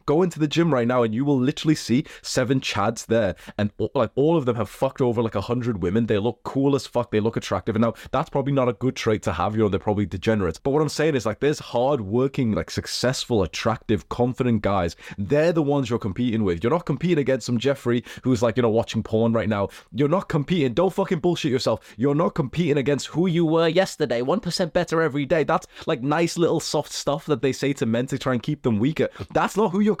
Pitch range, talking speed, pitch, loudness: 115-155 Hz, 245 wpm, 130 Hz, -23 LUFS